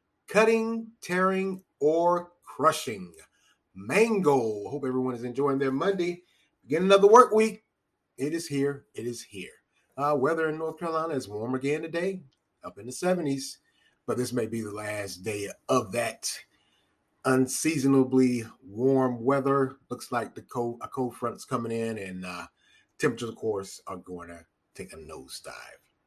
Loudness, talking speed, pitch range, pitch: -27 LUFS, 150 wpm, 120-170 Hz, 135 Hz